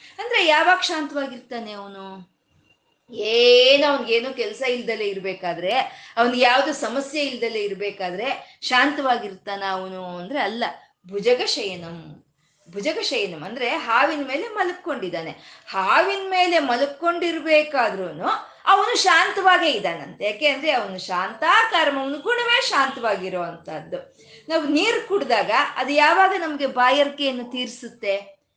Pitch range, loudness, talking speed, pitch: 205-340 Hz, -21 LUFS, 95 wpm, 275 Hz